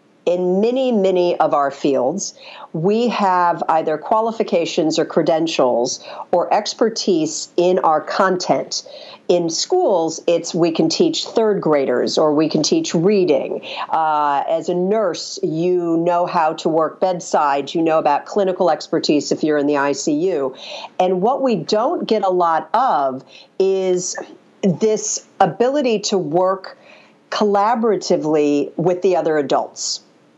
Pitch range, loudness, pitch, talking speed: 160-205 Hz, -18 LUFS, 180 Hz, 135 wpm